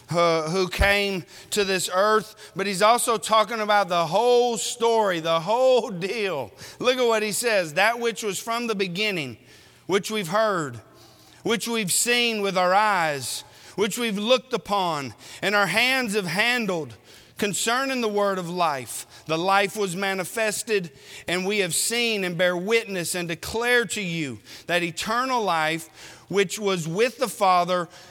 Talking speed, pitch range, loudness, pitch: 155 wpm, 170-225 Hz, -23 LUFS, 200 Hz